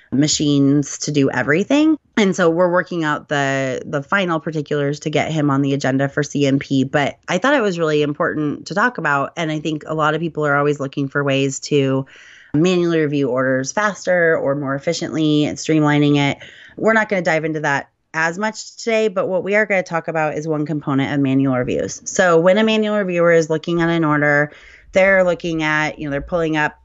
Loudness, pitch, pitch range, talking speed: -18 LUFS, 150 Hz, 140-170 Hz, 215 wpm